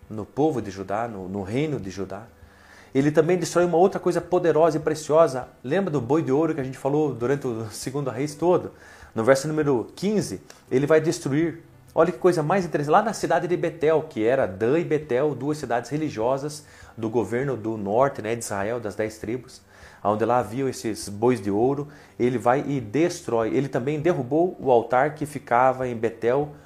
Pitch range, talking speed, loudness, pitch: 115-160 Hz, 195 wpm, -24 LUFS, 135 Hz